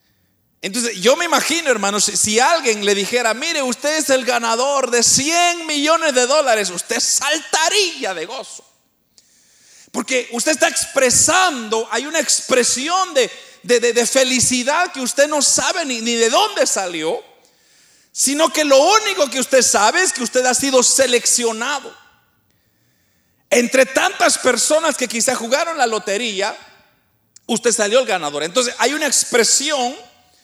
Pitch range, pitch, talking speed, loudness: 235-300 Hz, 255 Hz, 145 wpm, -15 LUFS